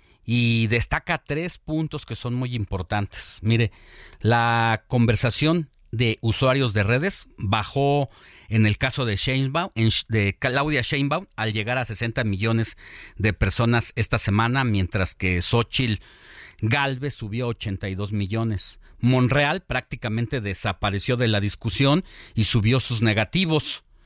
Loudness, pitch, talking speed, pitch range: -23 LUFS, 115 Hz, 130 wpm, 105-130 Hz